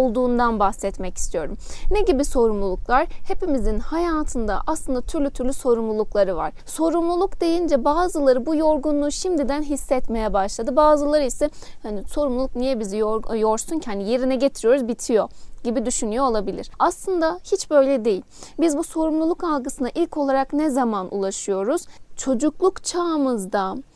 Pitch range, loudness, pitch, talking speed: 230-315 Hz, -22 LUFS, 275 Hz, 130 wpm